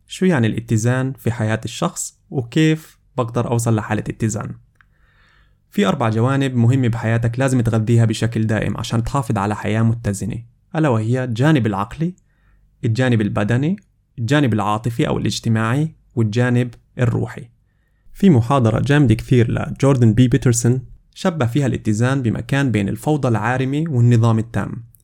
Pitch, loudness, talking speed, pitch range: 120 Hz, -18 LUFS, 125 wpm, 110-135 Hz